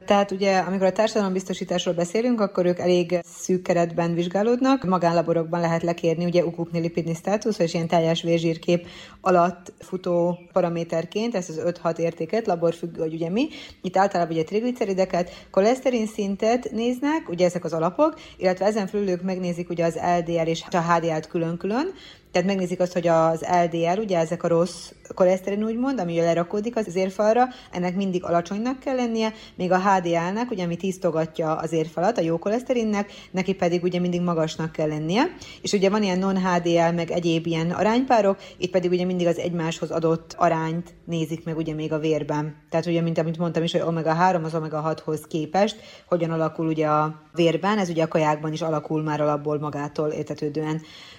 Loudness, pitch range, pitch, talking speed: -24 LUFS, 165-195 Hz, 175 Hz, 170 wpm